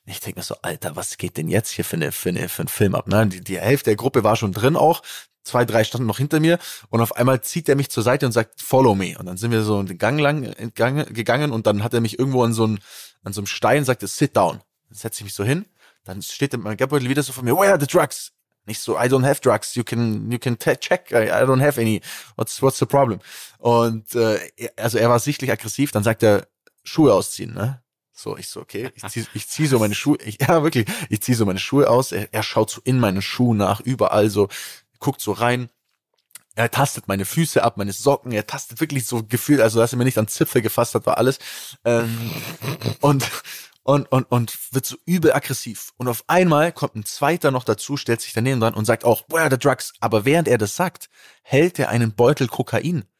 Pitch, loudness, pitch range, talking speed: 120 Hz, -20 LUFS, 110-140 Hz, 240 wpm